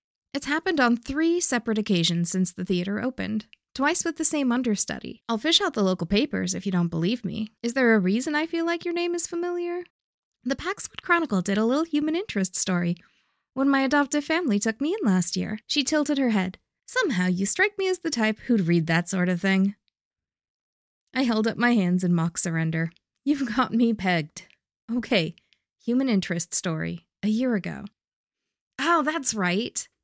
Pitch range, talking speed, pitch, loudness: 185-295 Hz, 190 wpm, 230 Hz, -25 LUFS